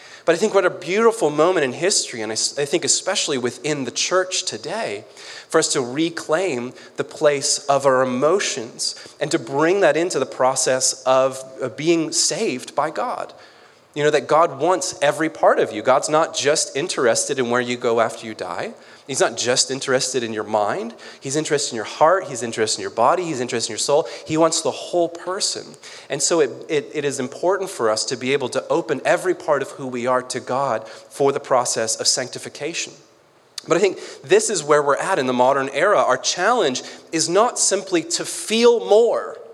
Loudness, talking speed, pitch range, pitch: -20 LUFS, 200 wpm, 125-180 Hz, 145 Hz